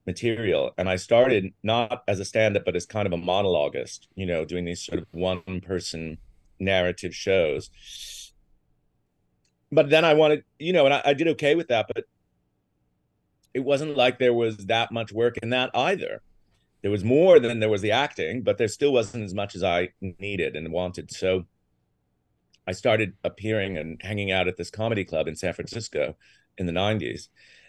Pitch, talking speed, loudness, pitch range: 100 Hz, 185 wpm, -24 LUFS, 90-115 Hz